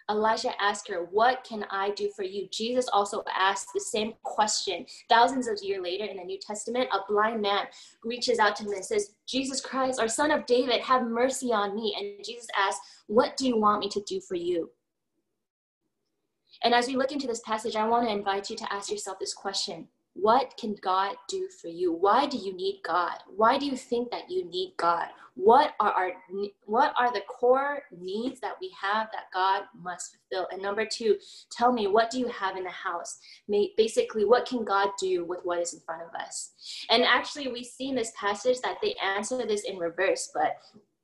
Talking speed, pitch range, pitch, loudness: 210 wpm, 195-255 Hz, 220 Hz, -28 LUFS